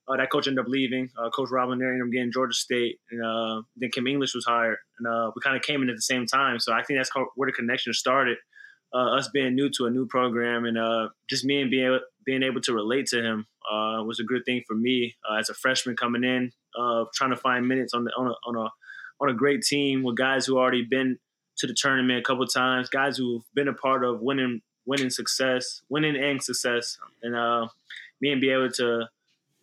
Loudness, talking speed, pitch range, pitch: -26 LUFS, 245 wpm, 120-135 Hz, 125 Hz